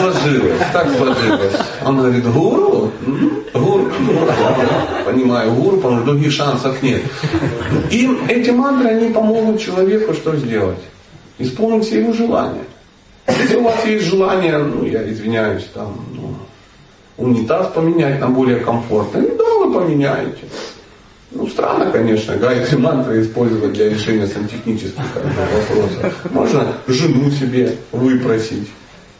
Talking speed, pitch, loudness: 125 wpm, 135 Hz, -15 LUFS